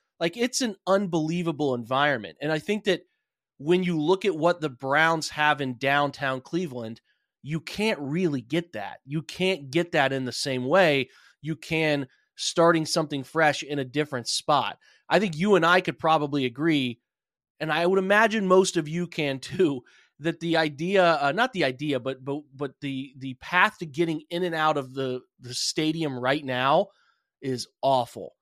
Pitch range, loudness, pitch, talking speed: 135-175 Hz, -25 LUFS, 155 Hz, 180 wpm